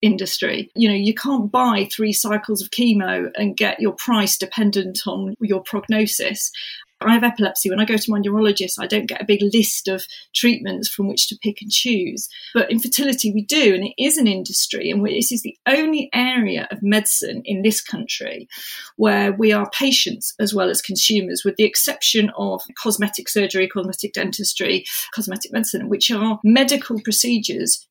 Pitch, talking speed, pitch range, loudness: 215 Hz, 180 wpm, 200-230 Hz, -19 LUFS